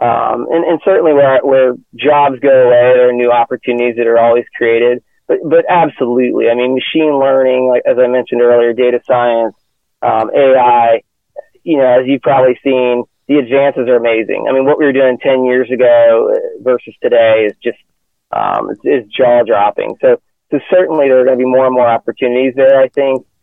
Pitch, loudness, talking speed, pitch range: 130 Hz, -11 LUFS, 185 wpm, 120-140 Hz